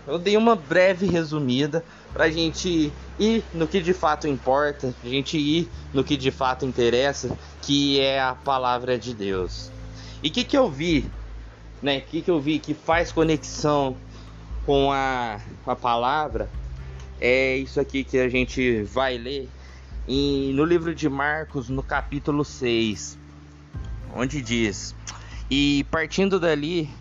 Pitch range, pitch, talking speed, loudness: 125-155 Hz, 135 Hz, 150 wpm, -23 LUFS